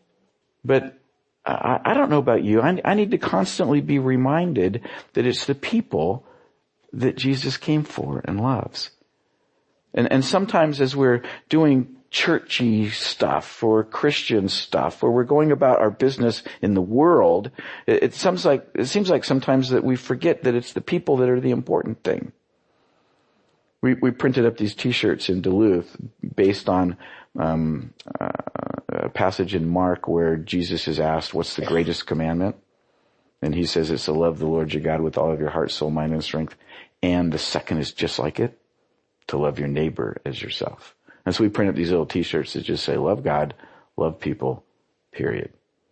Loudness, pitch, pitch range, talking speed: -22 LUFS, 115 Hz, 85-135 Hz, 175 wpm